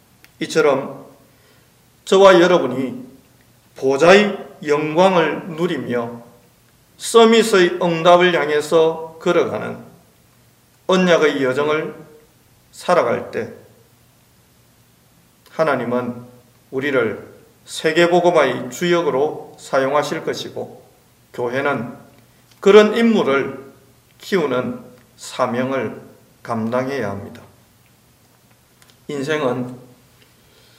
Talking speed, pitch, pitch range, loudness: 175 characters per minute, 135 Hz, 125-175 Hz, -17 LUFS